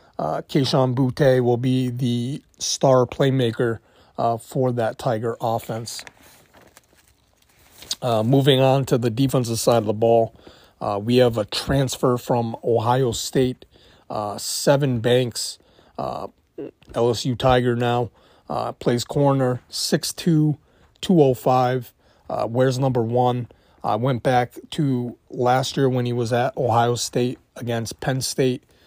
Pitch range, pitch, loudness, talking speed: 120-130 Hz, 125 Hz, -21 LUFS, 130 wpm